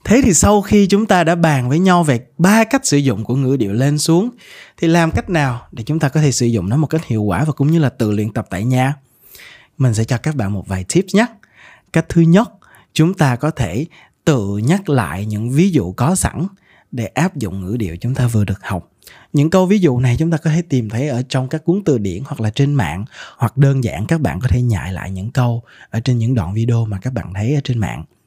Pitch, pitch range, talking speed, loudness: 130 Hz, 115-160 Hz, 260 wpm, -16 LUFS